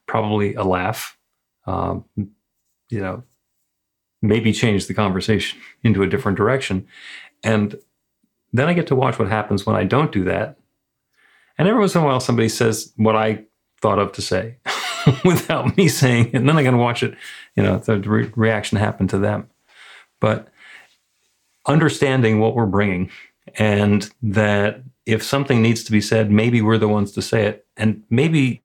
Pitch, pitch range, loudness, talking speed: 110 Hz, 105-125 Hz, -19 LUFS, 170 wpm